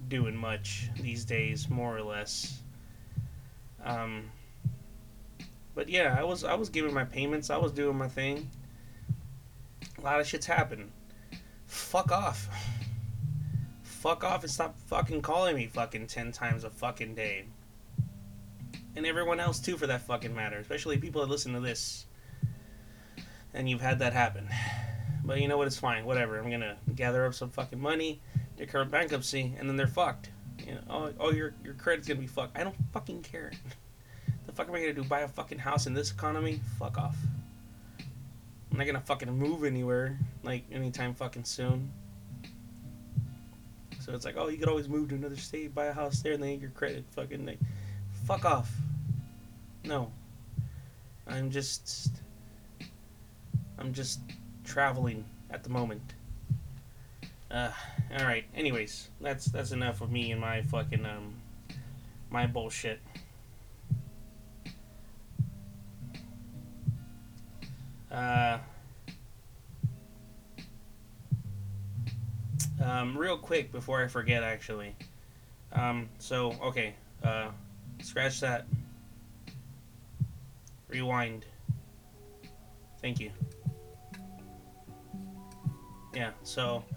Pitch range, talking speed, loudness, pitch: 110-135 Hz, 130 wpm, -34 LUFS, 125 Hz